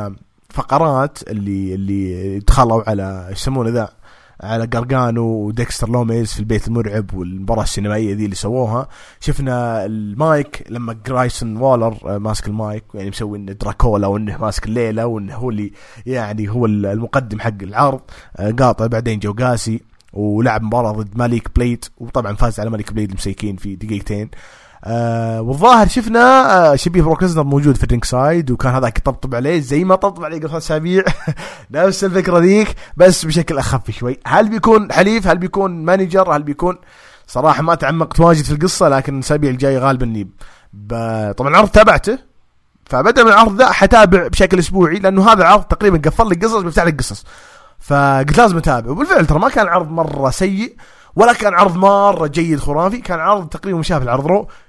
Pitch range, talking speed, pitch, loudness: 110-170 Hz, 160 wpm, 130 Hz, -14 LUFS